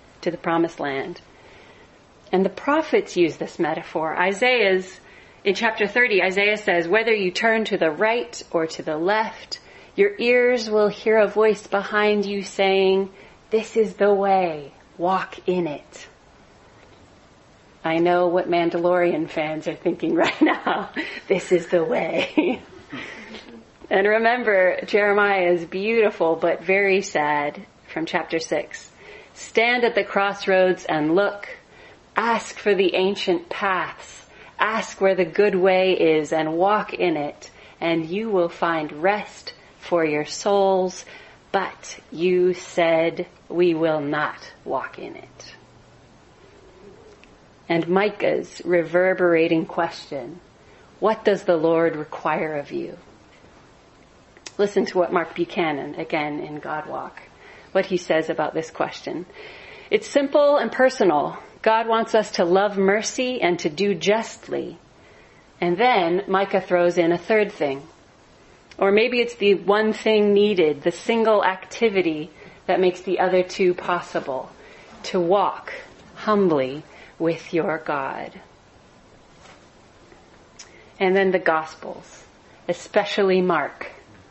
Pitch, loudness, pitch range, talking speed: 185 Hz, -21 LUFS, 170-210 Hz, 130 wpm